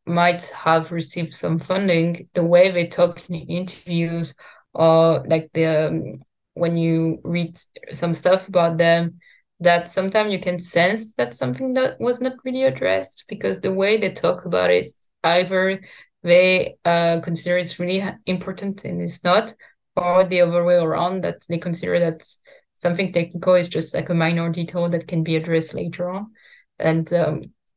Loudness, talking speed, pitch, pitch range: -20 LUFS, 165 wpm, 175 Hz, 165-180 Hz